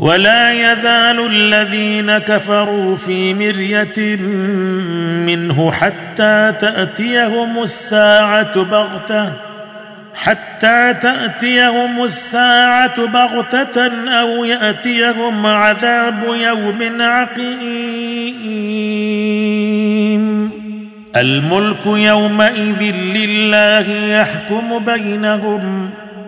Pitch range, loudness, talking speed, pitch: 210-235 Hz, -13 LUFS, 55 wpm, 215 Hz